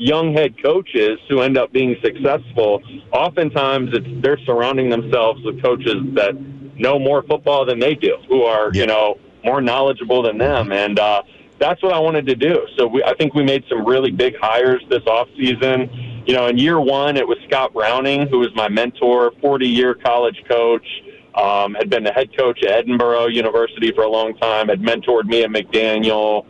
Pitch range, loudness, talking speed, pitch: 115-140 Hz, -17 LUFS, 195 wpm, 125 Hz